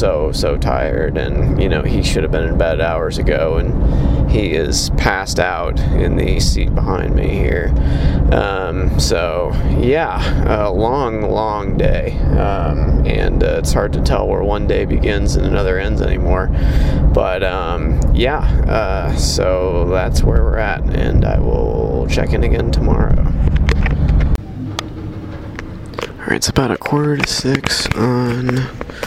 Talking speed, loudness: 150 wpm, -16 LUFS